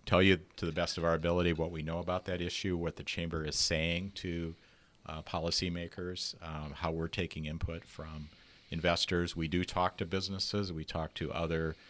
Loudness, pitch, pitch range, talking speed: -34 LUFS, 85 Hz, 80-90 Hz, 190 wpm